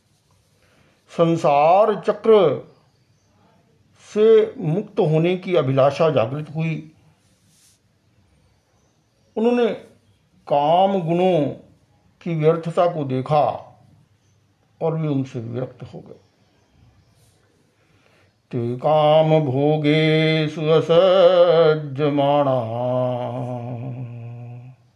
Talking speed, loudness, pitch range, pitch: 65 wpm, -19 LUFS, 120-165 Hz, 145 Hz